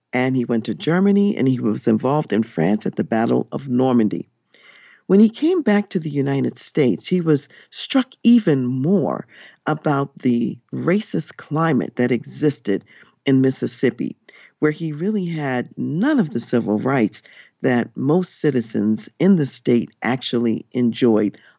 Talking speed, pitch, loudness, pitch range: 150 wpm, 140 Hz, -20 LUFS, 120-180 Hz